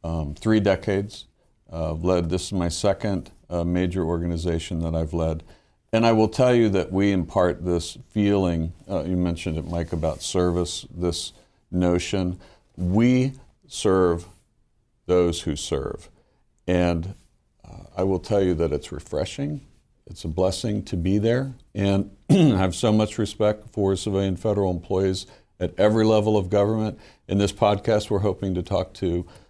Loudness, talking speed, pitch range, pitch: -24 LUFS, 160 wpm, 85-105 Hz, 95 Hz